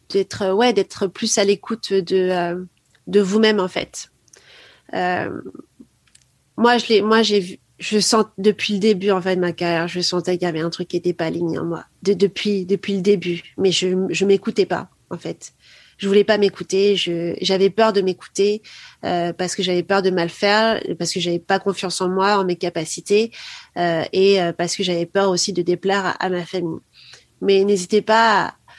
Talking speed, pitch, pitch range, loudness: 205 wpm, 195 Hz, 180-205 Hz, -19 LUFS